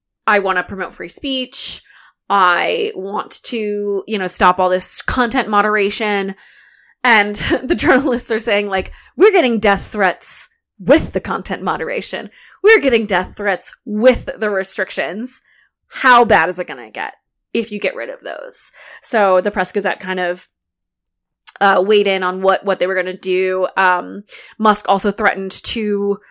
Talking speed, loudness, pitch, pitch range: 165 wpm, -16 LUFS, 200 Hz, 185-220 Hz